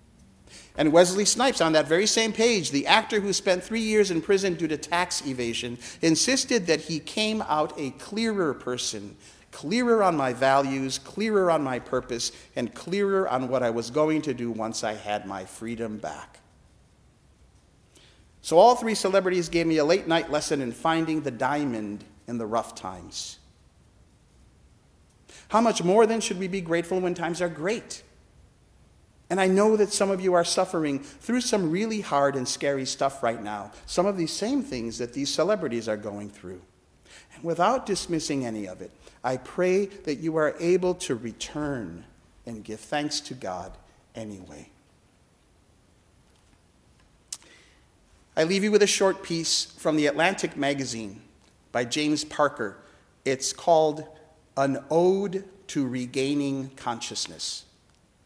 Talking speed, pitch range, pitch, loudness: 155 wpm, 120-190 Hz, 150 Hz, -25 LUFS